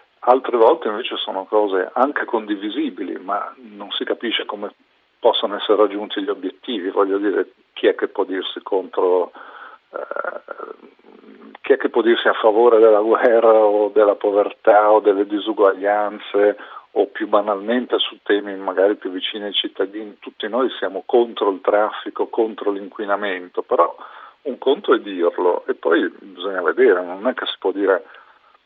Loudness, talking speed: -19 LUFS, 155 wpm